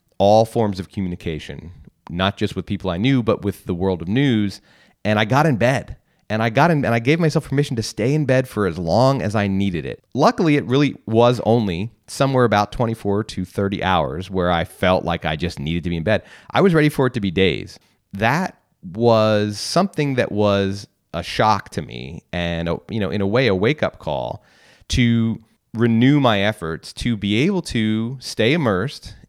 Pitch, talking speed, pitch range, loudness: 110 Hz, 205 wpm, 95-125 Hz, -19 LUFS